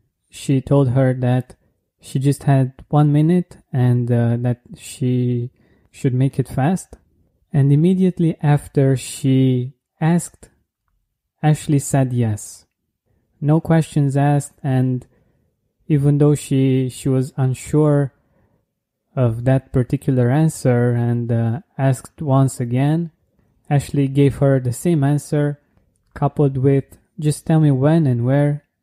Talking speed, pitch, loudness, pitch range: 120 wpm, 135 Hz, -18 LUFS, 125-145 Hz